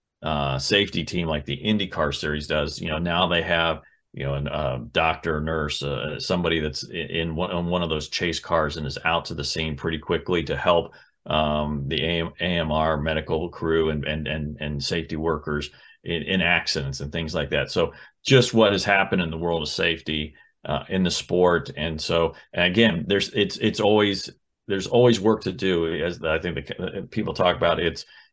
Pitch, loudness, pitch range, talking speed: 80 Hz, -24 LUFS, 75-90 Hz, 205 wpm